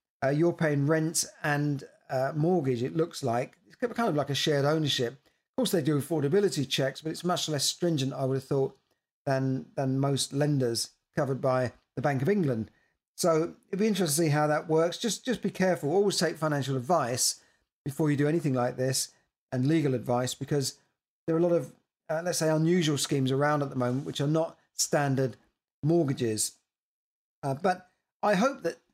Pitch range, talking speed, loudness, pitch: 135-170 Hz, 195 wpm, -28 LUFS, 150 Hz